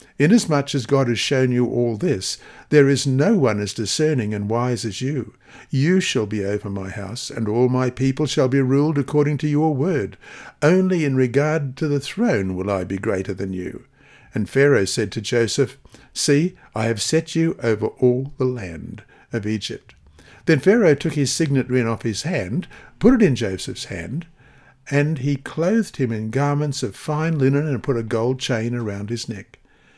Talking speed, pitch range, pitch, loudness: 190 wpm, 115-145 Hz, 130 Hz, -20 LUFS